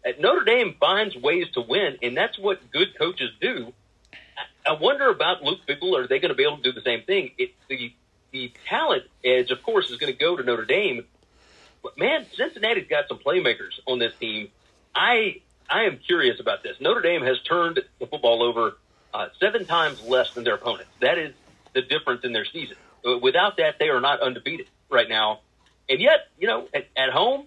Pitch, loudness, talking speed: 310 Hz, -23 LUFS, 205 wpm